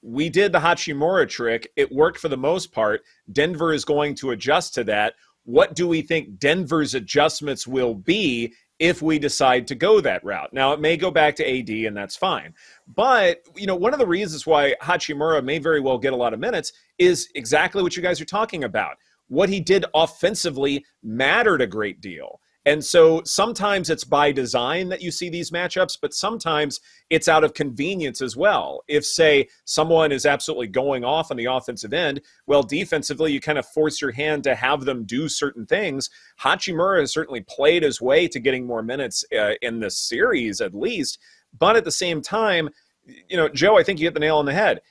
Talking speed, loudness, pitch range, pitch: 205 wpm, -21 LUFS, 140-175 Hz, 155 Hz